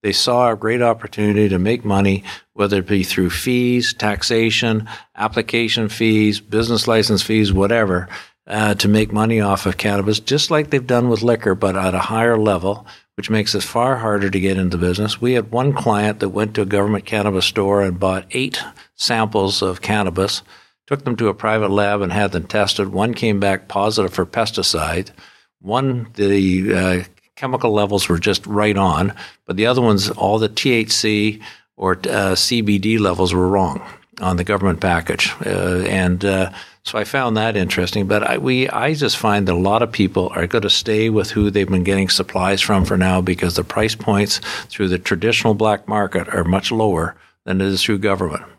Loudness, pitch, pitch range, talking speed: -17 LUFS, 105 Hz, 95-110 Hz, 190 wpm